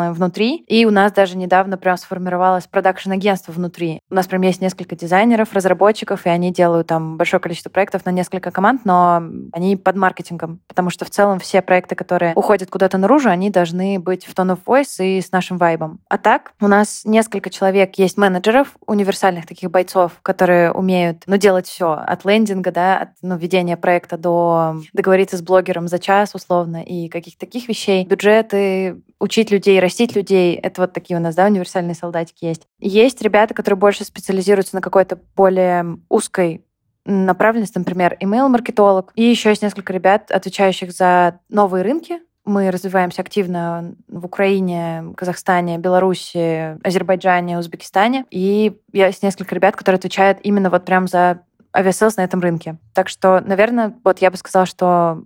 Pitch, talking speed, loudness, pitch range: 185 Hz, 165 wpm, -16 LUFS, 180-200 Hz